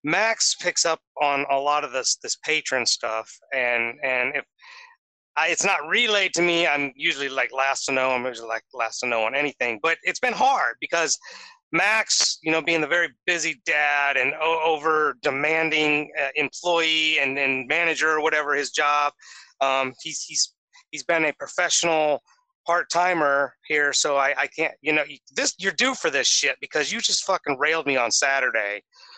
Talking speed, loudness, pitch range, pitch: 185 wpm, -22 LUFS, 135-170 Hz, 150 Hz